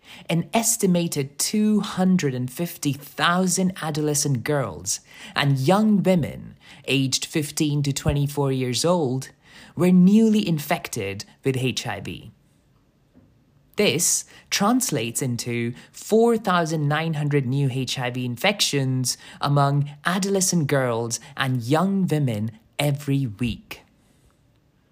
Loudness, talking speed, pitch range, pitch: -22 LUFS, 80 wpm, 130-175 Hz, 145 Hz